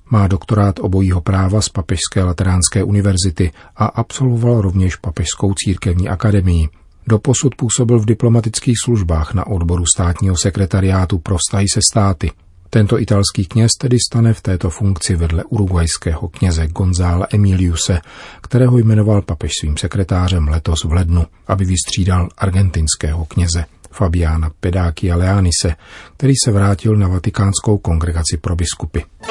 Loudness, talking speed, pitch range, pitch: -15 LUFS, 125 wpm, 85-105 Hz, 95 Hz